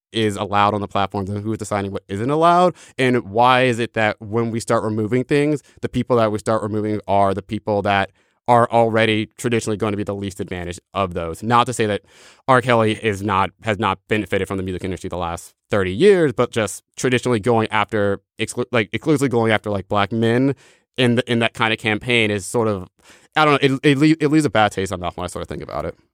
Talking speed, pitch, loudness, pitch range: 240 wpm, 110 Hz, -19 LUFS, 100-120 Hz